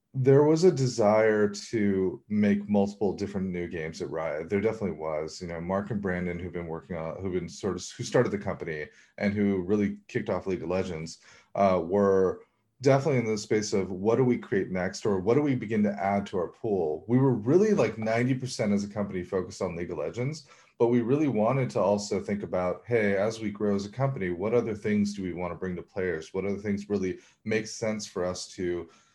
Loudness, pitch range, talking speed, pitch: -28 LUFS, 95-115 Hz, 225 wpm, 105 Hz